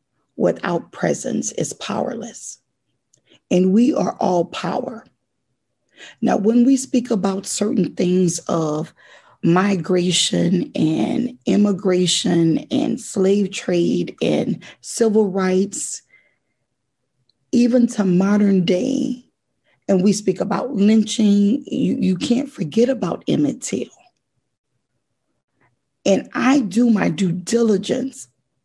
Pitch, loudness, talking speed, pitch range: 200 Hz, -19 LUFS, 100 wpm, 180-240 Hz